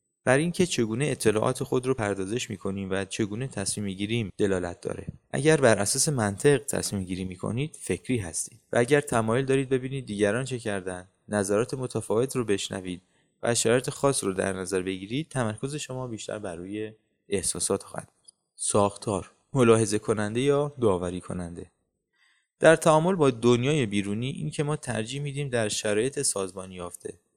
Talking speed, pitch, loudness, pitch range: 155 wpm, 110 Hz, -26 LUFS, 100-135 Hz